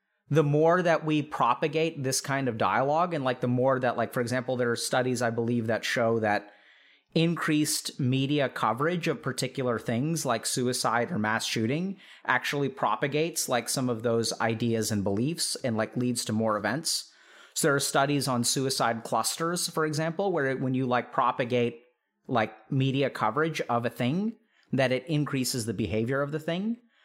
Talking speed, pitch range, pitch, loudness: 180 wpm, 120-155 Hz, 130 Hz, -28 LUFS